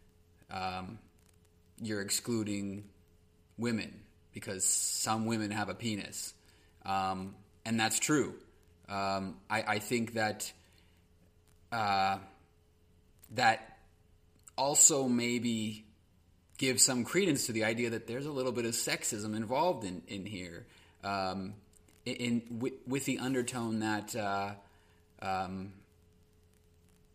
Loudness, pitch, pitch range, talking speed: -33 LUFS, 100 Hz, 85-115 Hz, 110 wpm